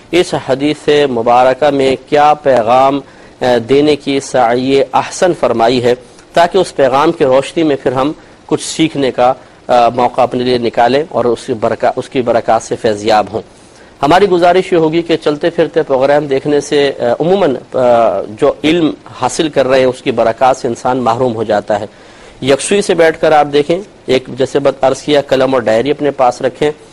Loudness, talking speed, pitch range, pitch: -12 LUFS, 175 wpm, 125-150 Hz, 135 Hz